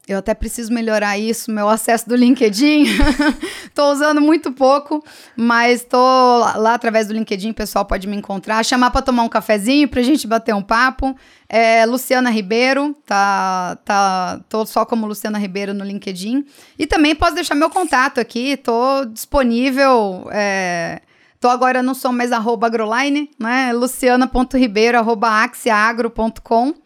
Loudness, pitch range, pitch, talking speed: -16 LUFS, 220-265 Hz, 240 Hz, 145 wpm